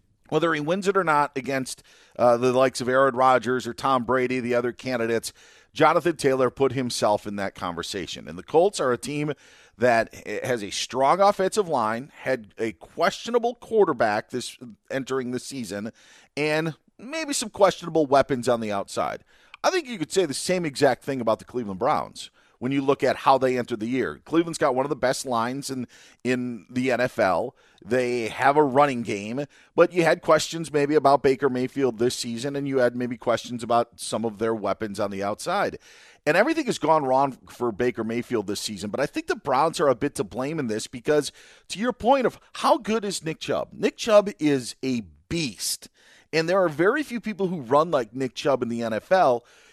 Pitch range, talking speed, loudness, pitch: 120-165 Hz, 200 wpm, -24 LUFS, 135 Hz